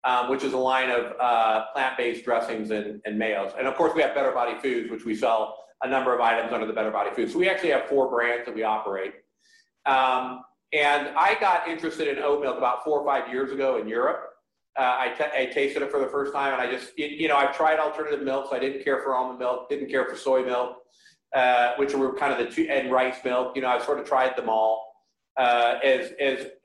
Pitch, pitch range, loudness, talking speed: 130 Hz, 120-140 Hz, -25 LUFS, 245 wpm